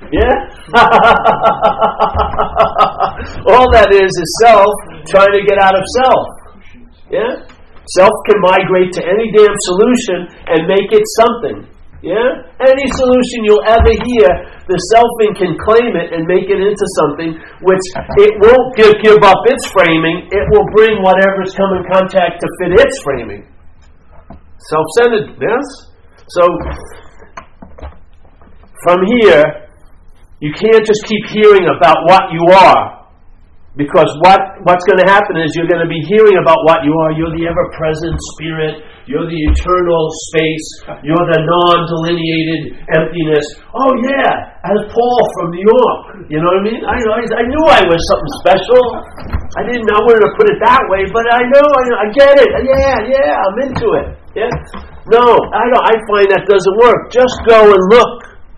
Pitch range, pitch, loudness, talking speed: 165-225 Hz, 190 Hz, -10 LUFS, 160 wpm